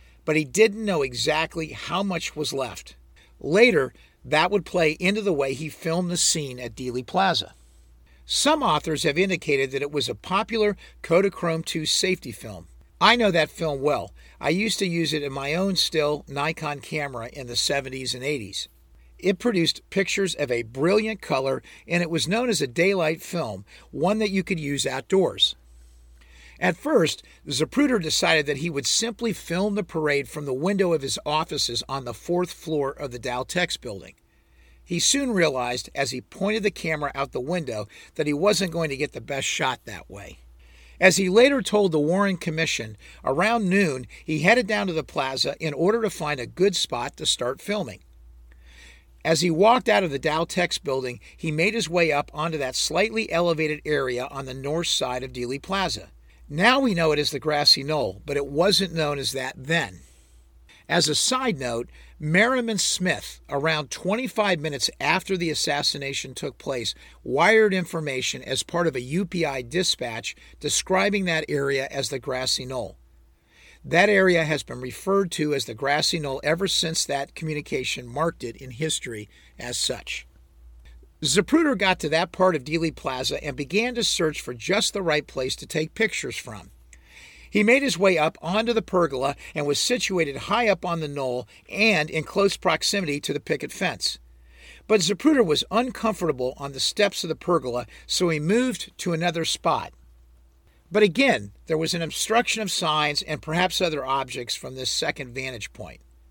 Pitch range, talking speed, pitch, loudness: 130-185 Hz, 180 wpm, 155 Hz, -23 LUFS